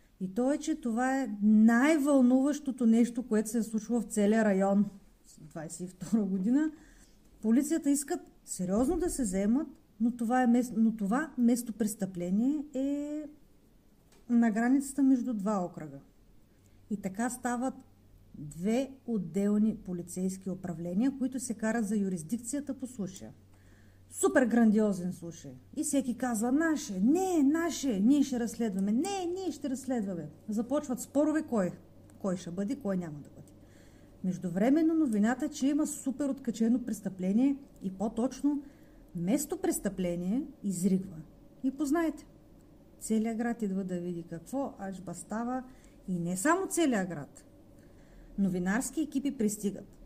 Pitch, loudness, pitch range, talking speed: 230 Hz, -31 LUFS, 195-270 Hz, 130 wpm